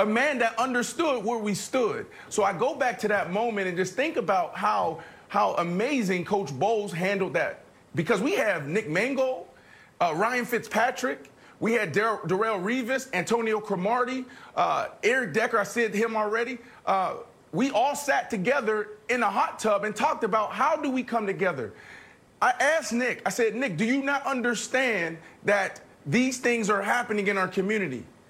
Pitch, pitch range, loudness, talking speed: 225 Hz, 200-250 Hz, -26 LUFS, 175 wpm